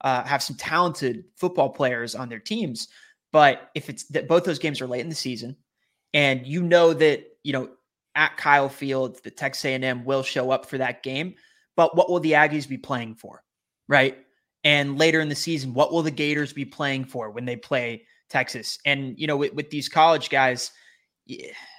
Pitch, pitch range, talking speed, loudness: 145 Hz, 130-165 Hz, 200 wpm, -23 LUFS